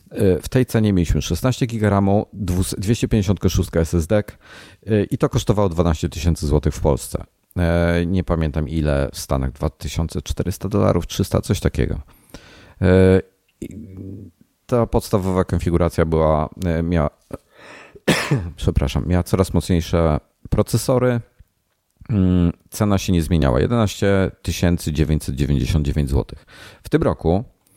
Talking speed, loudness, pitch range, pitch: 100 wpm, -20 LUFS, 80-105 Hz, 90 Hz